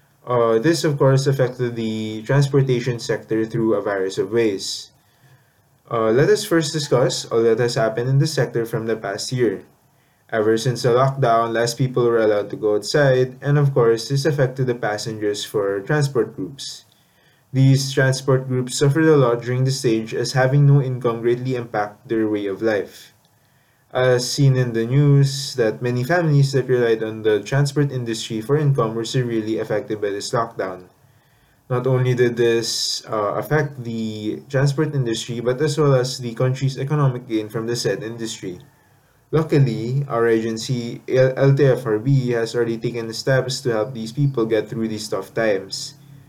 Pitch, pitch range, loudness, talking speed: 125 Hz, 115-140 Hz, -20 LUFS, 165 wpm